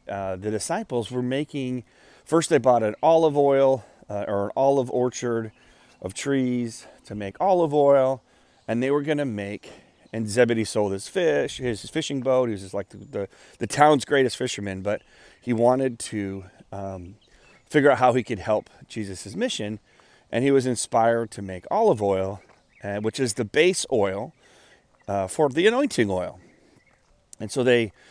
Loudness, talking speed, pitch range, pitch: -23 LUFS, 175 wpm, 105-135 Hz, 120 Hz